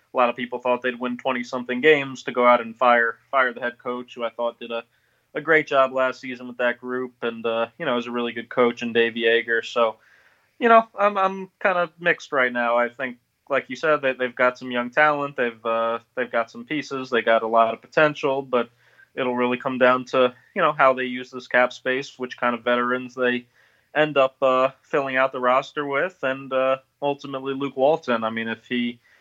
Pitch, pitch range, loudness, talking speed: 125 Hz, 120-135 Hz, -22 LUFS, 230 wpm